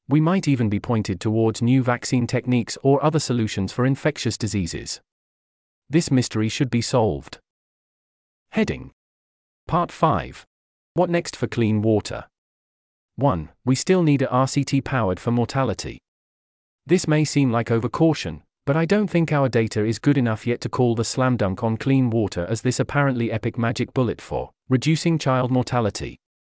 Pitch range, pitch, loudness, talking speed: 110-140 Hz, 120 Hz, -22 LUFS, 160 wpm